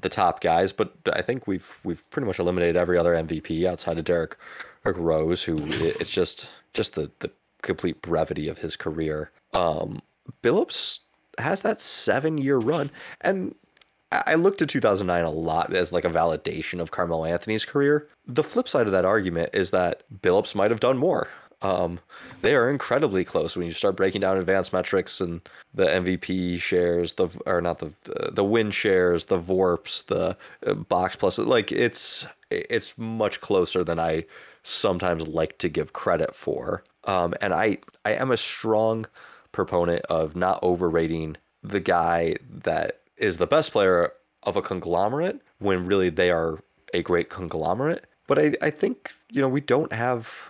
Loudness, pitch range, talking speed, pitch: -25 LUFS, 85-110 Hz, 170 wpm, 90 Hz